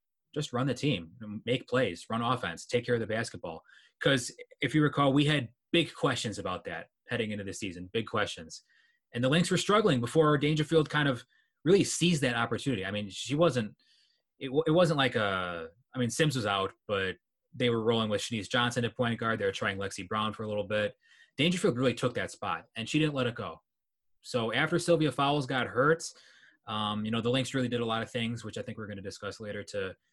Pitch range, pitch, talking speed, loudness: 105-145 Hz, 120 Hz, 225 wpm, -30 LUFS